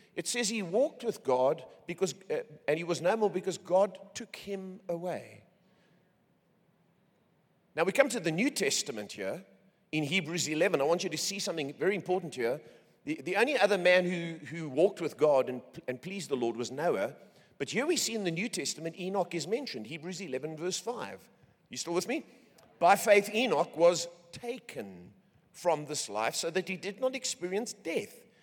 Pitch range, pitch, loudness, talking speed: 165-210 Hz, 185 Hz, -31 LUFS, 190 wpm